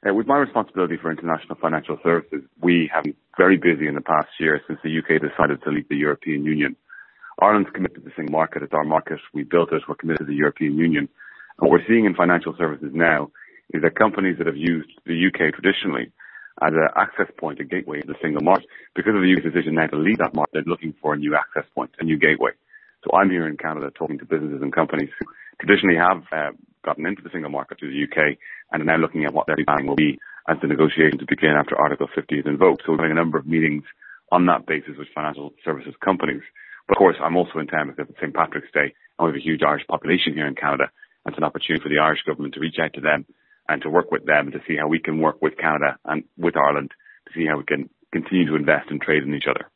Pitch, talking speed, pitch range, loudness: 80 Hz, 250 wpm, 75-85 Hz, -21 LUFS